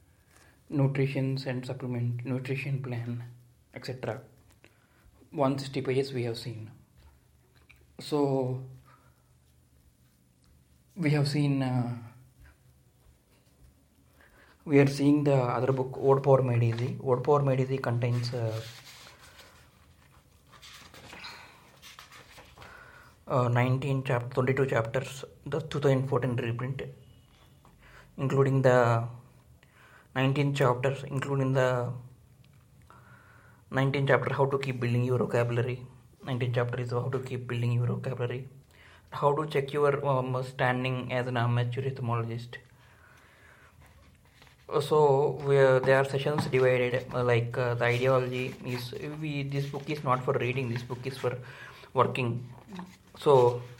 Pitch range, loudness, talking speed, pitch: 120-135 Hz, -28 LUFS, 110 wpm, 125 Hz